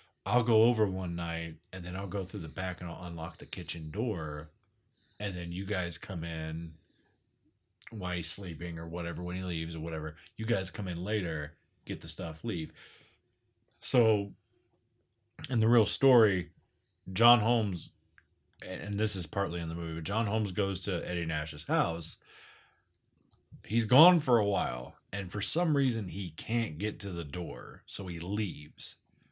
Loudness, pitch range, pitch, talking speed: -32 LUFS, 85-110 Hz, 95 Hz, 170 wpm